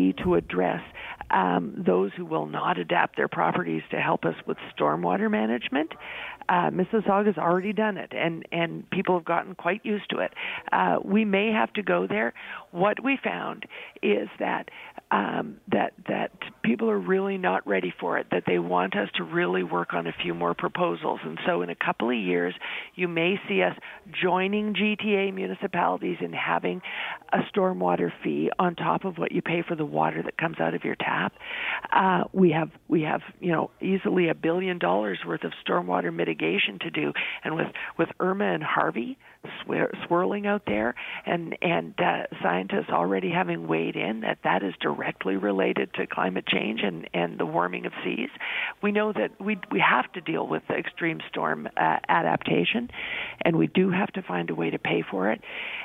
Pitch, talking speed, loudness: 180 Hz, 185 wpm, -26 LUFS